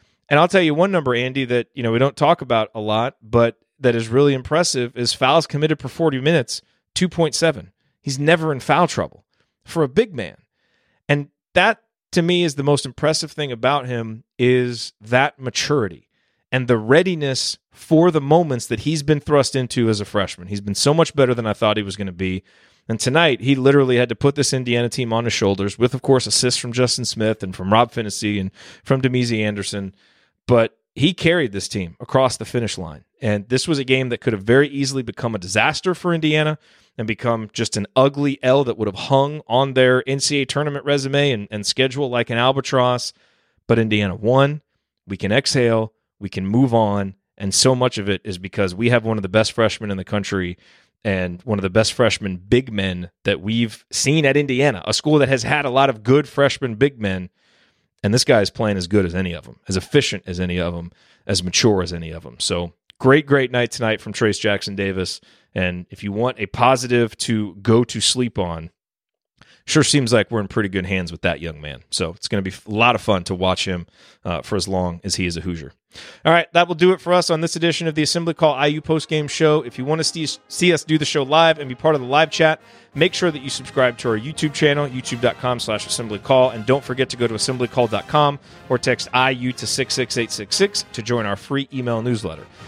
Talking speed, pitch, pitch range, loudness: 225 wpm, 125 Hz, 105-145 Hz, -19 LUFS